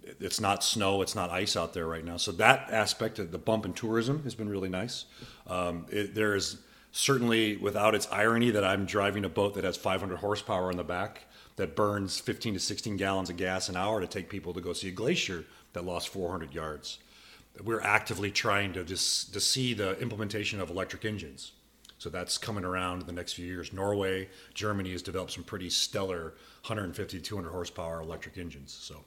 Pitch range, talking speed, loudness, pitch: 90-105 Hz, 205 wpm, -31 LUFS, 95 Hz